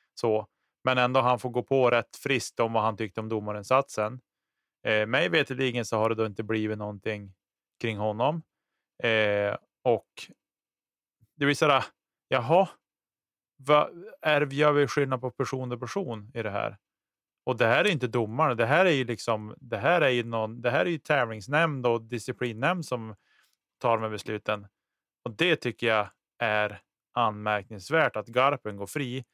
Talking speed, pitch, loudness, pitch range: 170 wpm, 120 Hz, -27 LUFS, 110-135 Hz